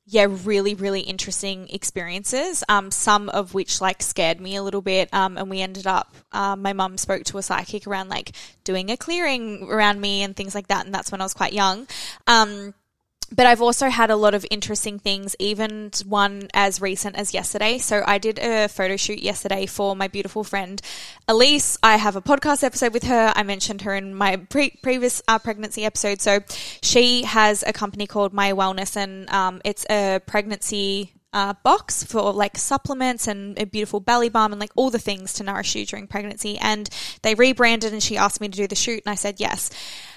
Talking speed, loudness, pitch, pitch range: 210 wpm, -21 LUFS, 205 Hz, 195-220 Hz